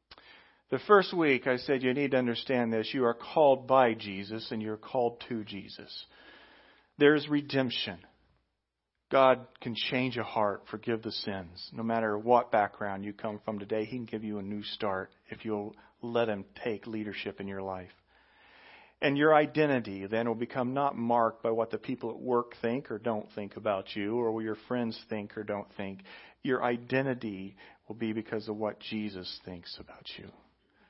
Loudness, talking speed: -31 LUFS, 180 wpm